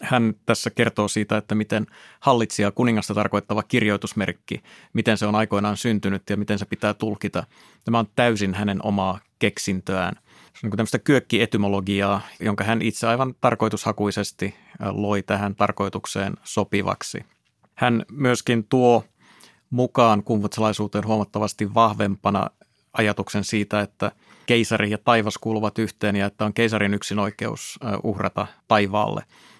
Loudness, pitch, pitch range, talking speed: -23 LUFS, 105 Hz, 100-115 Hz, 130 wpm